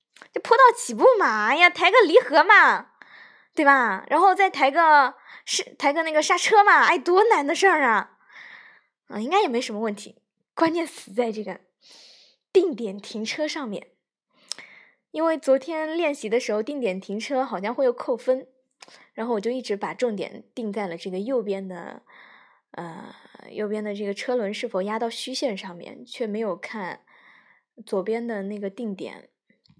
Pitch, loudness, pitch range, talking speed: 255 Hz, -22 LUFS, 215-330 Hz, 240 characters per minute